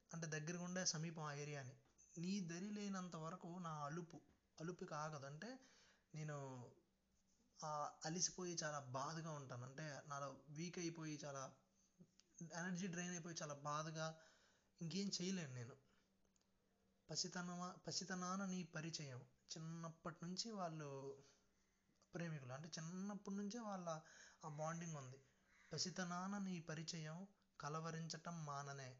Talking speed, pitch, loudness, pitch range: 110 wpm, 165 Hz, -50 LUFS, 150-180 Hz